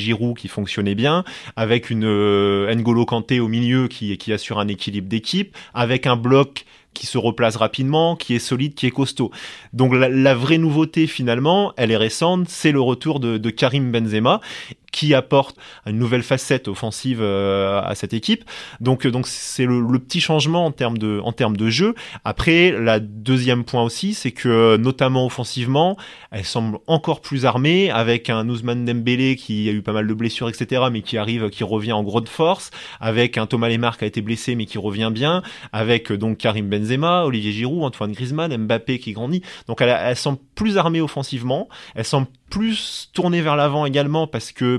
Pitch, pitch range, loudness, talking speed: 120 Hz, 110-140 Hz, -19 LUFS, 190 wpm